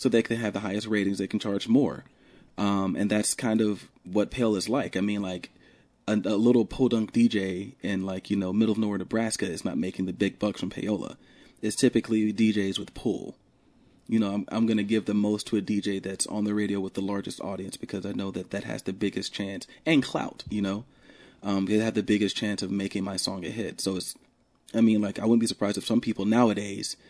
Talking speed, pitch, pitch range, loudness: 235 wpm, 105 Hz, 100-110 Hz, -27 LUFS